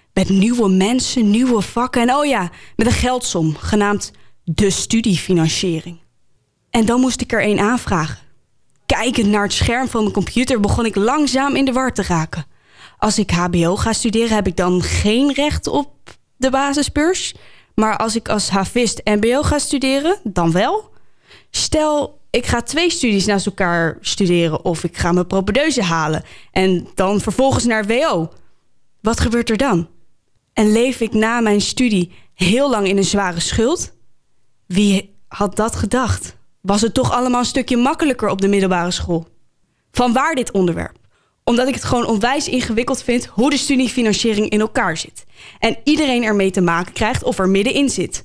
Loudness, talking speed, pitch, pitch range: -17 LUFS, 170 wpm, 215 Hz, 185-250 Hz